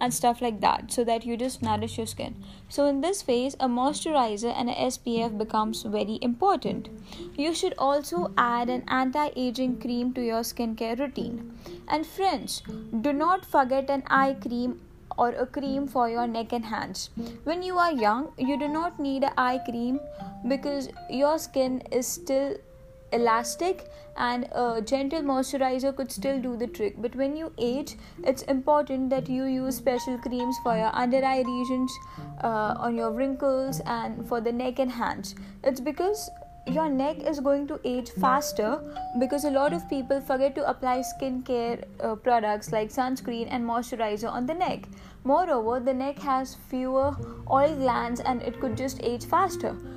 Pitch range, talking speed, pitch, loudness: 235-280 Hz, 170 wpm, 255 Hz, -27 LUFS